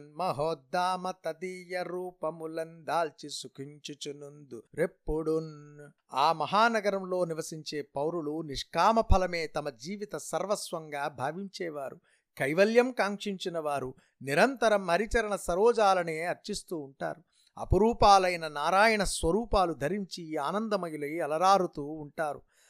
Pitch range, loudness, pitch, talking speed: 150-195 Hz, -29 LUFS, 170 Hz, 65 wpm